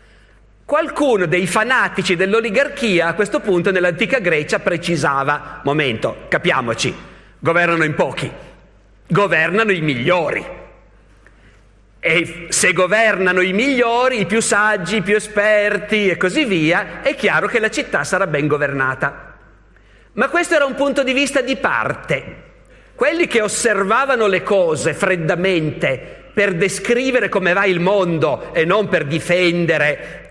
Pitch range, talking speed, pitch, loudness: 165-220 Hz, 130 wpm, 190 Hz, -16 LUFS